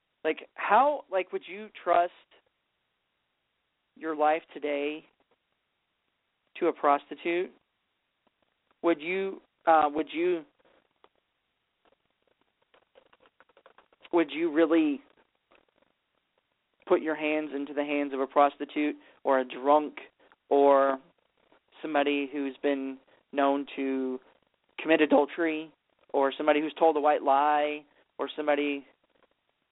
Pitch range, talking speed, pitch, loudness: 145-170 Hz, 100 wpm, 150 Hz, -28 LUFS